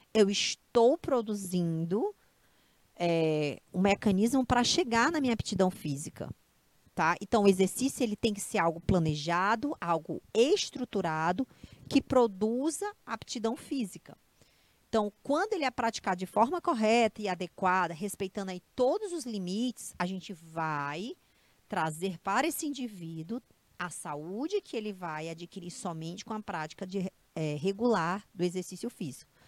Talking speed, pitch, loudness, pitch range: 135 wpm, 200 Hz, -31 LUFS, 175-245 Hz